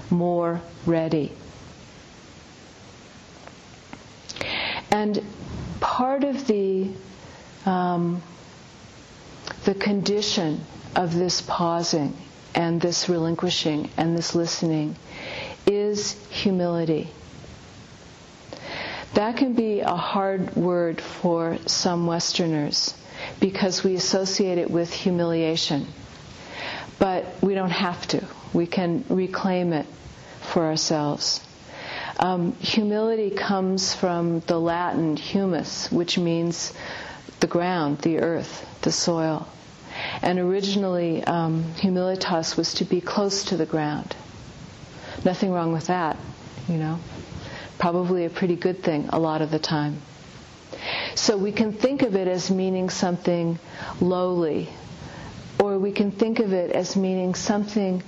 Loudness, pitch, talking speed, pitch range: -24 LUFS, 175 Hz, 110 wpm, 165-195 Hz